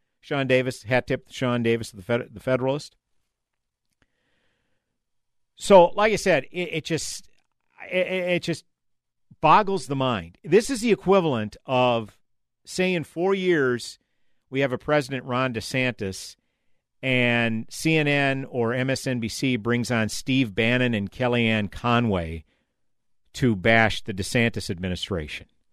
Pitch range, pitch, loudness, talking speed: 115-150 Hz, 125 Hz, -23 LUFS, 130 wpm